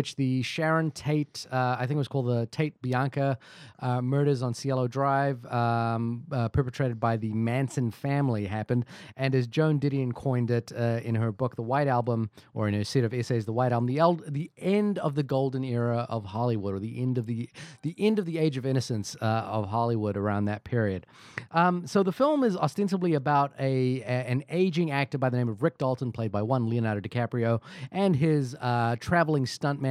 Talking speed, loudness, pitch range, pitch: 205 wpm, -28 LUFS, 115-145 Hz, 130 Hz